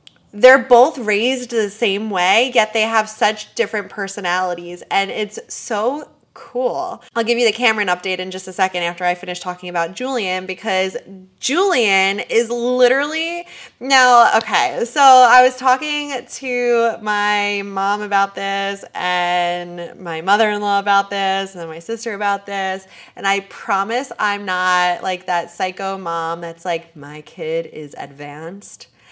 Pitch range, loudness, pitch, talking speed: 180-235 Hz, -17 LUFS, 200 Hz, 155 wpm